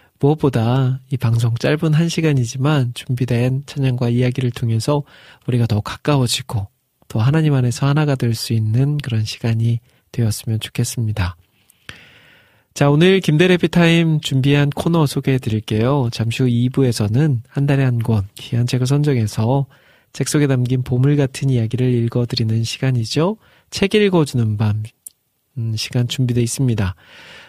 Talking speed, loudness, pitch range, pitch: 315 characters per minute, -18 LUFS, 115-145 Hz, 125 Hz